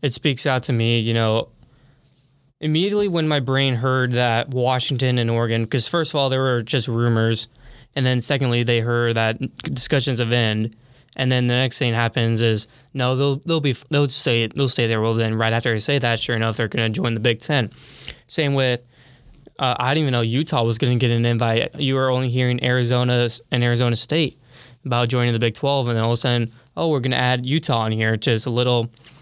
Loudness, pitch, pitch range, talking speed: -20 LUFS, 125 Hz, 115-135 Hz, 225 wpm